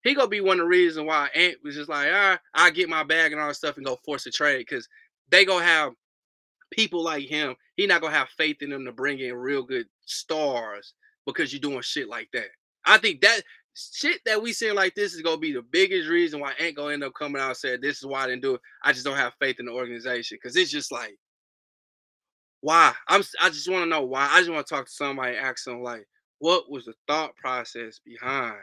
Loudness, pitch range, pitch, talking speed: -23 LUFS, 135-215 Hz, 155 Hz, 255 wpm